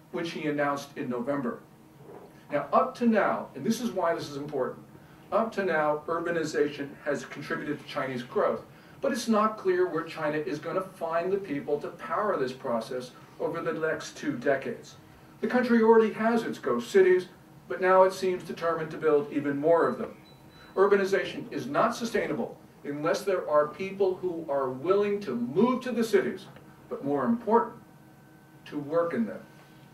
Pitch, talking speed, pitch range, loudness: 170 Hz, 175 wpm, 155-200 Hz, -28 LUFS